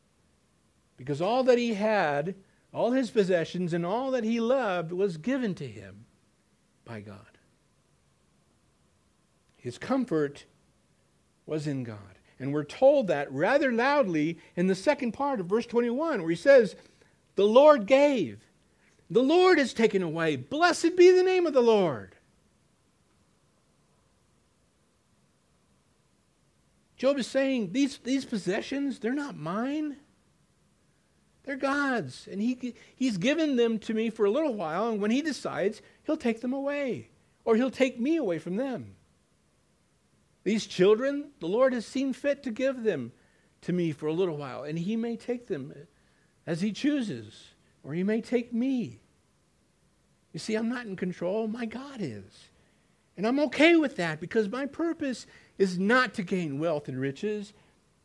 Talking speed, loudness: 150 wpm, -27 LUFS